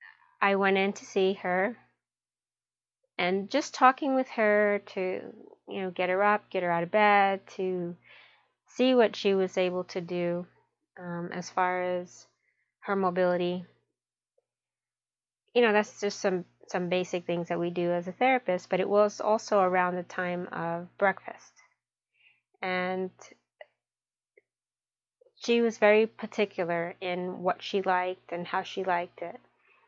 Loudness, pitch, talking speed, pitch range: -28 LUFS, 185 Hz, 145 wpm, 180-210 Hz